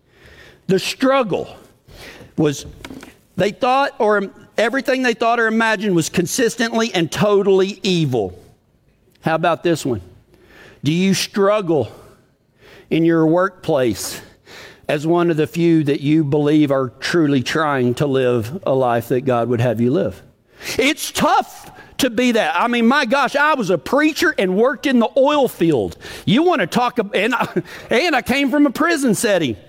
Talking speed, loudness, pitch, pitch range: 160 wpm, -17 LUFS, 190 Hz, 155-245 Hz